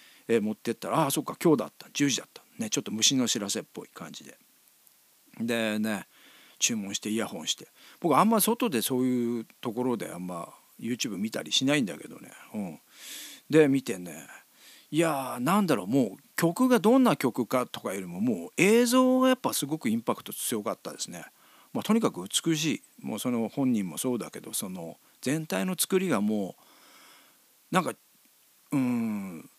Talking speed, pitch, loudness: 355 characters per minute, 135 Hz, -28 LUFS